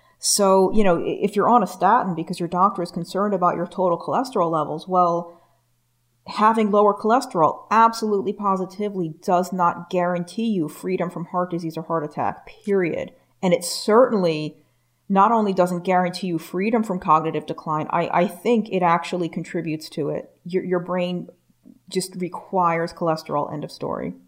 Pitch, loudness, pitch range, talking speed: 180 Hz, -22 LUFS, 170-195 Hz, 160 wpm